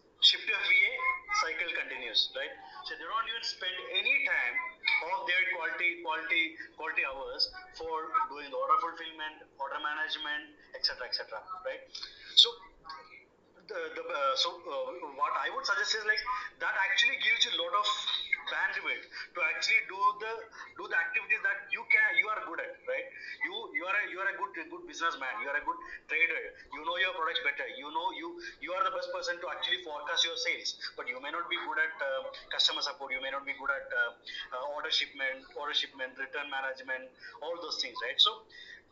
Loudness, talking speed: -31 LUFS, 190 wpm